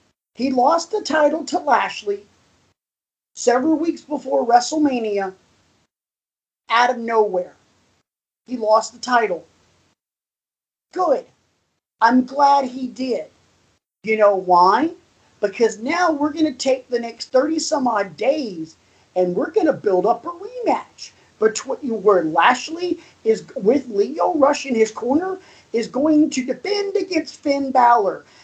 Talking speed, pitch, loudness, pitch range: 125 wpm, 255 Hz, -19 LUFS, 225-310 Hz